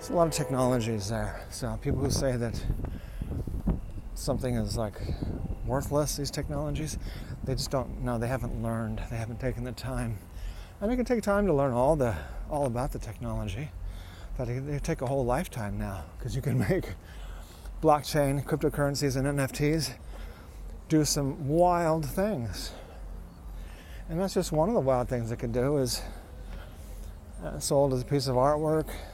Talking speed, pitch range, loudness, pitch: 165 wpm, 90-140 Hz, -30 LUFS, 125 Hz